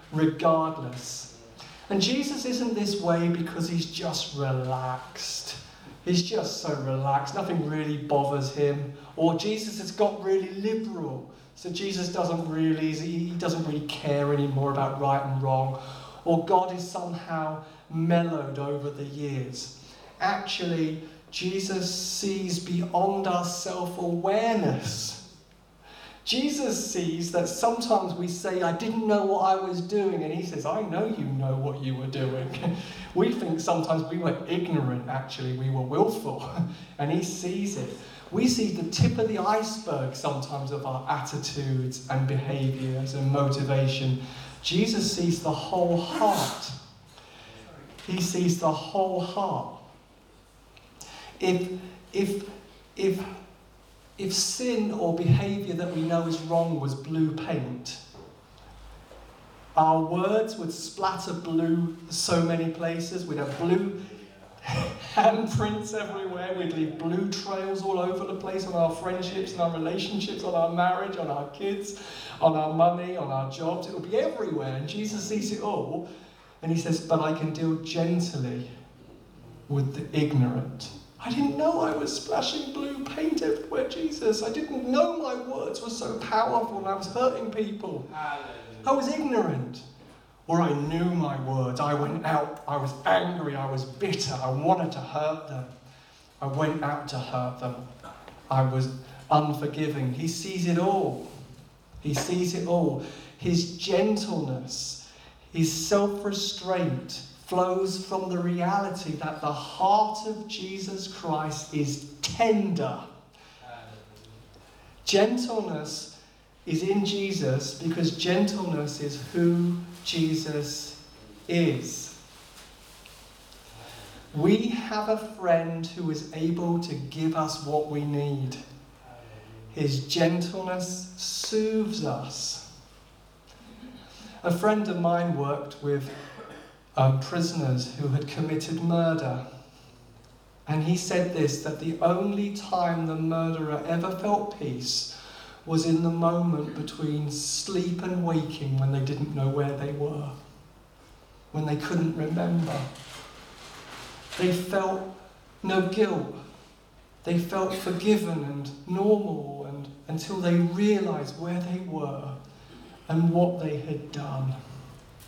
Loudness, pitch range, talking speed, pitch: -28 LUFS, 145-190 Hz, 130 wpm, 165 Hz